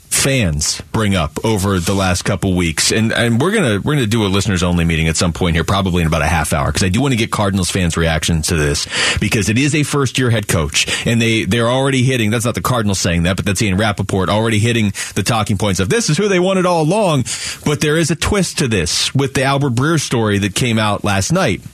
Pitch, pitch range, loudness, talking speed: 105 Hz, 95-130 Hz, -15 LUFS, 255 wpm